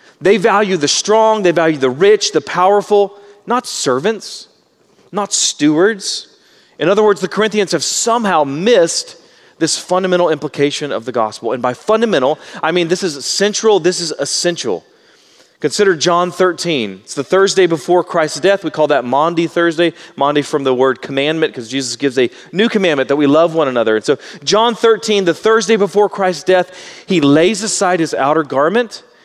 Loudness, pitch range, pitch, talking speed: -14 LUFS, 150-210 Hz, 180 Hz, 170 wpm